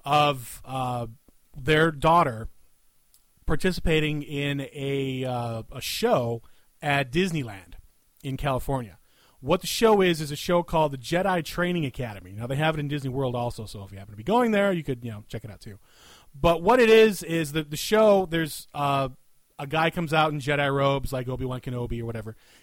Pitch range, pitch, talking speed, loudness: 120-165 Hz, 140 Hz, 195 wpm, -25 LUFS